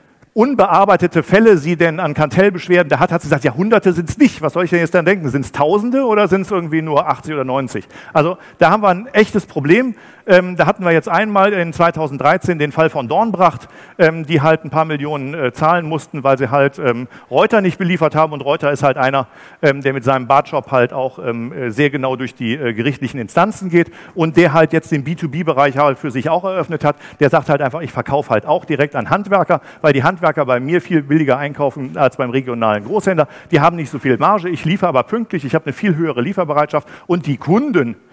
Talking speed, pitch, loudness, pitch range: 230 wpm, 160 Hz, -15 LUFS, 140-180 Hz